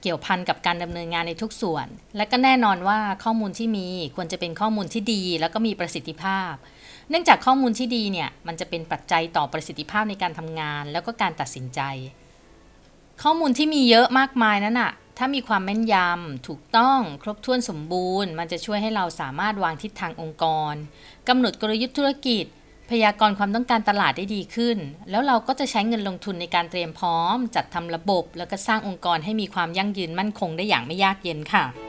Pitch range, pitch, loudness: 170-225 Hz, 195 Hz, -23 LUFS